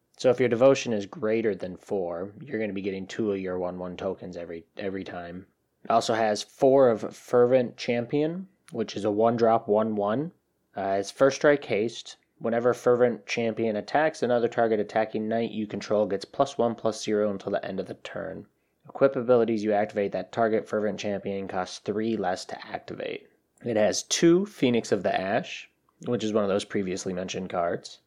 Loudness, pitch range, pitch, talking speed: -26 LUFS, 100-120 Hz, 110 Hz, 190 wpm